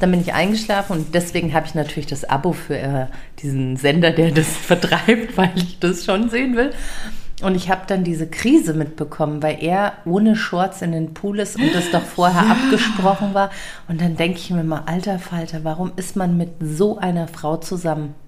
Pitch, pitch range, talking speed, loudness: 175 Hz, 160-195 Hz, 195 wpm, -19 LUFS